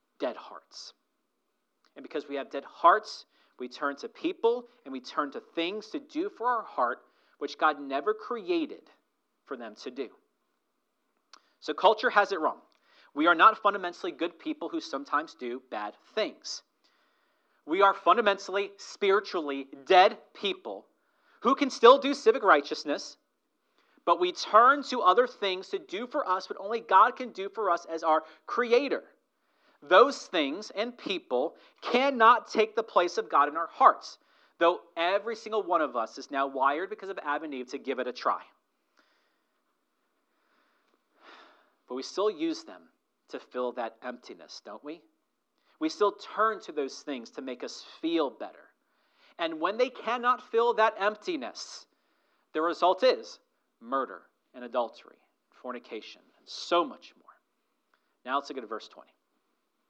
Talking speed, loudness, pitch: 155 wpm, -28 LUFS, 210 Hz